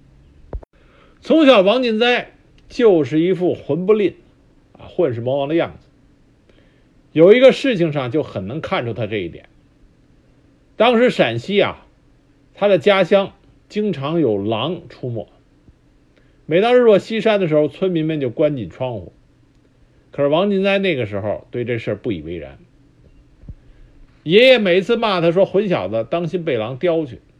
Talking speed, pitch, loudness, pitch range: 220 characters per minute, 160 Hz, -17 LUFS, 135-195 Hz